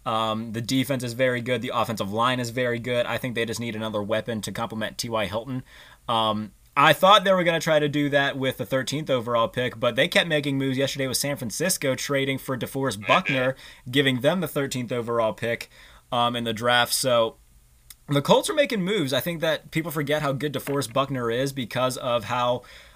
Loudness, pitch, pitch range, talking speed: -24 LUFS, 130 Hz, 115-140 Hz, 210 wpm